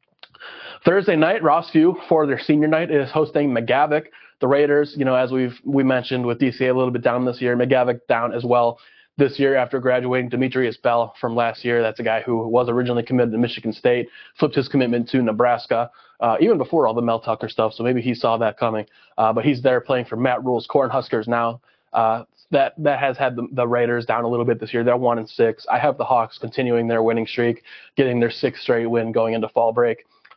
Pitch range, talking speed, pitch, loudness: 115-135 Hz, 225 wpm, 125 Hz, -20 LUFS